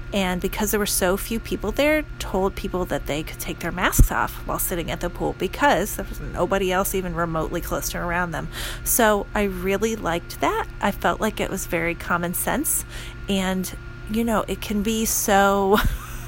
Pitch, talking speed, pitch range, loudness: 180 Hz, 195 wpm, 165-200 Hz, -23 LUFS